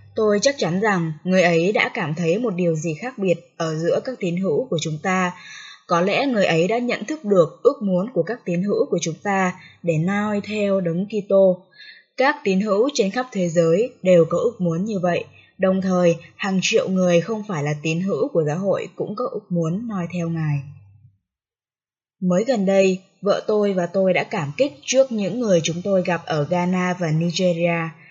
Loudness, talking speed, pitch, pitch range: -21 LUFS, 205 wpm, 180 Hz, 170-205 Hz